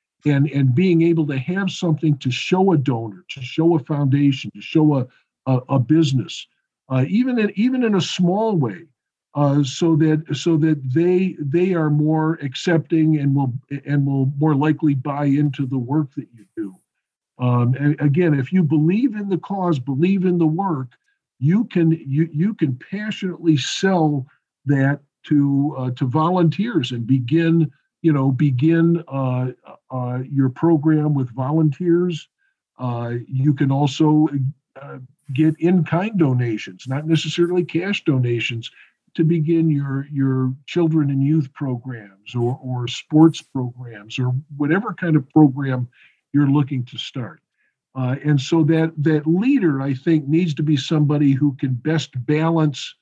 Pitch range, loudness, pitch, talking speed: 135-165 Hz, -19 LUFS, 150 Hz, 155 wpm